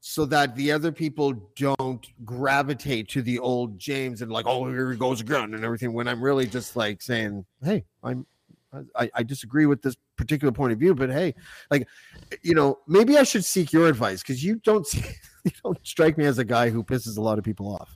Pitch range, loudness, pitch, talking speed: 115-150 Hz, -24 LUFS, 130 Hz, 220 wpm